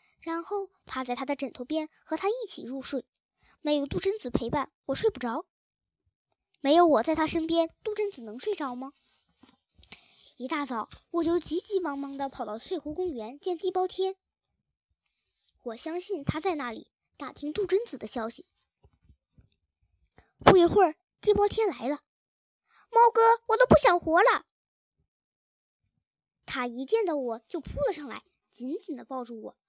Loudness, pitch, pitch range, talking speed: -28 LUFS, 320 Hz, 270-380 Hz, 220 characters per minute